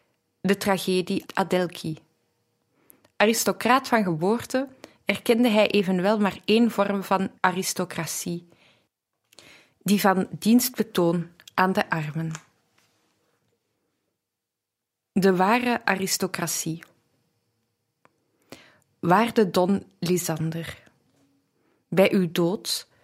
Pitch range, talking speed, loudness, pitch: 170-205 Hz, 75 wpm, -24 LUFS, 185 Hz